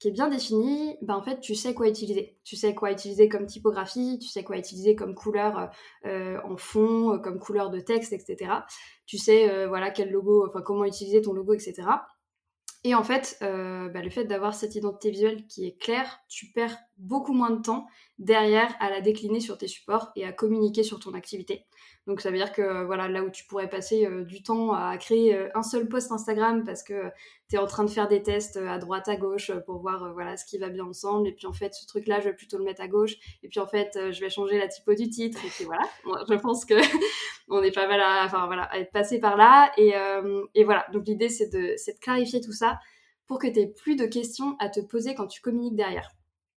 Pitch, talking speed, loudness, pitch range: 210 Hz, 245 wpm, -26 LUFS, 195-225 Hz